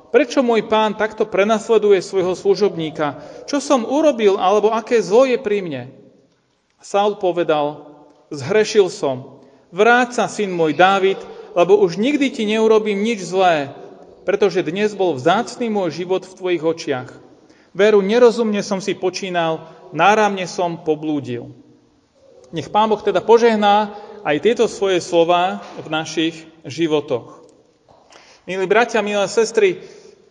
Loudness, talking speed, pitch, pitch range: -17 LUFS, 130 wpm, 200 Hz, 170-225 Hz